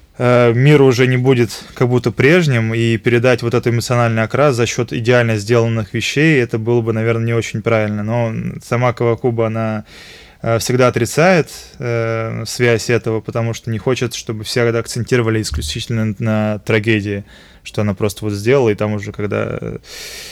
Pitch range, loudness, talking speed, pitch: 110-125 Hz, -16 LUFS, 155 wpm, 115 Hz